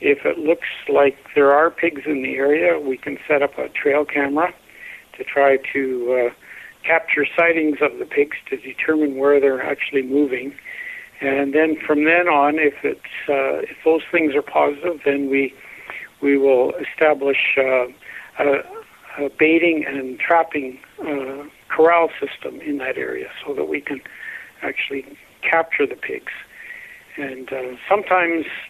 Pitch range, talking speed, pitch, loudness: 140-170 Hz, 155 wpm, 150 Hz, -19 LUFS